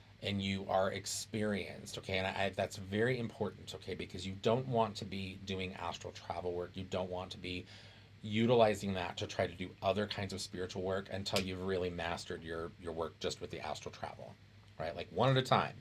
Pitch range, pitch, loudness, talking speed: 95-105 Hz, 95 Hz, -37 LUFS, 215 wpm